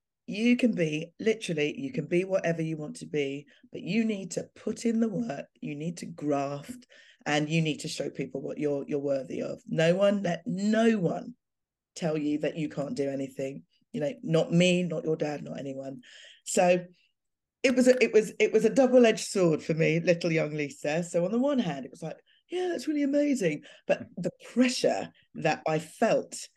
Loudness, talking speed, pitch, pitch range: -28 LUFS, 205 wpm, 175 Hz, 150-230 Hz